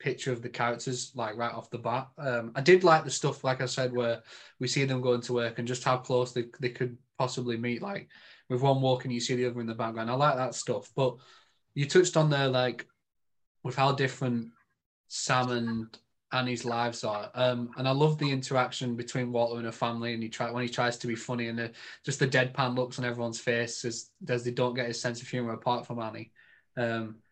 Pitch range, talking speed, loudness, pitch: 120-130 Hz, 230 wpm, -30 LUFS, 125 Hz